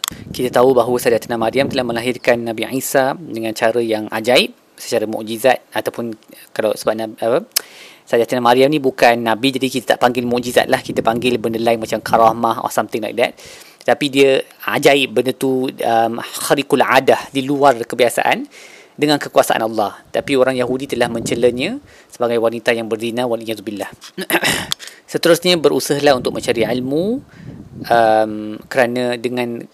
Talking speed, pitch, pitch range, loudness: 150 wpm, 125 Hz, 115-130 Hz, -16 LUFS